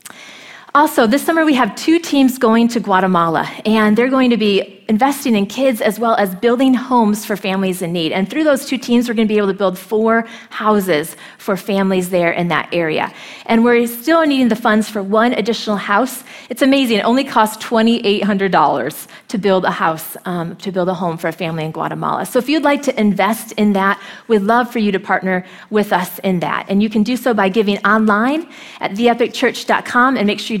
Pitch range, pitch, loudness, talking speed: 195-245 Hz, 220 Hz, -15 LUFS, 220 wpm